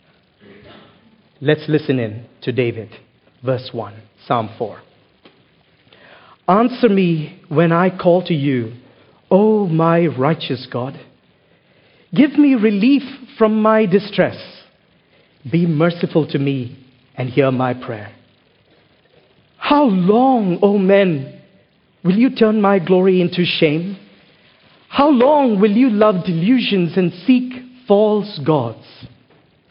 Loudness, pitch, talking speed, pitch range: -16 LUFS, 175 Hz, 110 wpm, 135-215 Hz